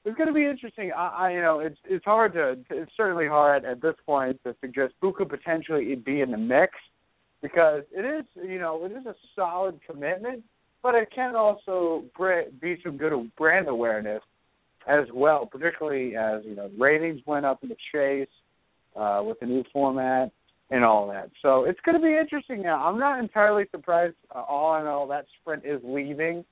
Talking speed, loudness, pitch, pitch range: 195 wpm, -26 LUFS, 160 Hz, 135-195 Hz